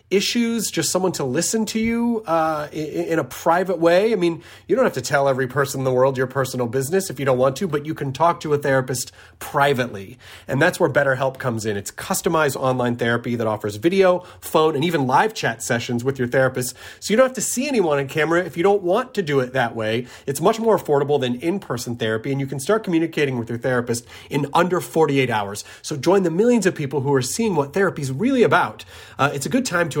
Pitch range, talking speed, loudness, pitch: 130-175 Hz, 240 wpm, -20 LUFS, 145 Hz